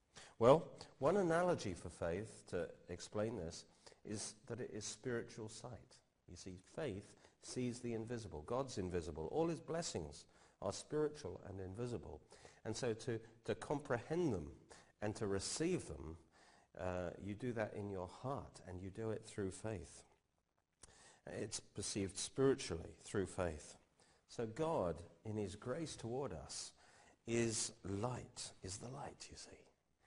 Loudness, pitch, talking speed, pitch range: -43 LUFS, 105 Hz, 140 wpm, 90-120 Hz